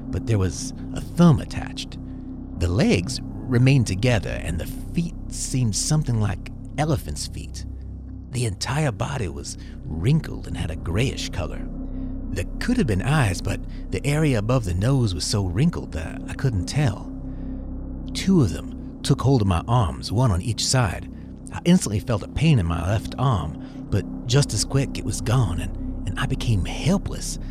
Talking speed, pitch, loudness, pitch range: 170 wpm, 110 Hz, -24 LUFS, 90-130 Hz